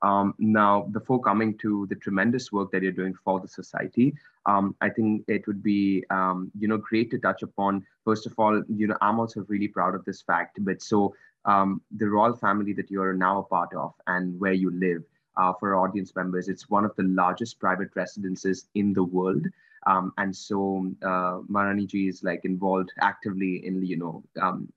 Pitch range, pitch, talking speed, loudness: 95-105 Hz, 100 Hz, 205 wpm, -26 LUFS